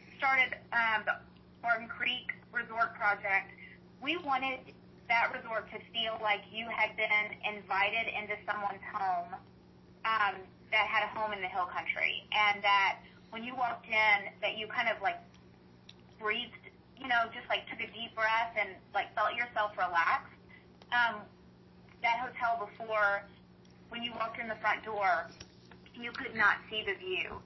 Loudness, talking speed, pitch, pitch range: -32 LUFS, 155 wpm, 215 Hz, 200-235 Hz